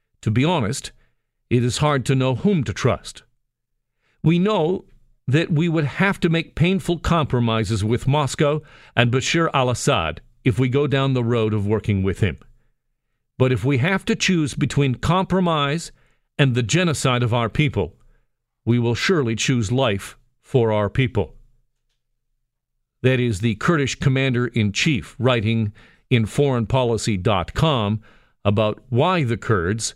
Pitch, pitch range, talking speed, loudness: 125 Hz, 115-145 Hz, 145 wpm, -20 LUFS